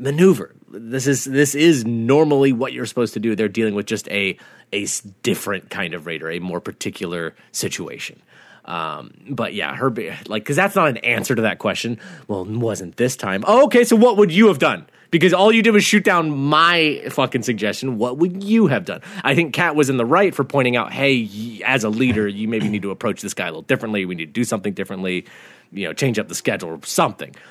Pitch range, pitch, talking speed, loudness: 105-165 Hz, 125 Hz, 230 wpm, -19 LUFS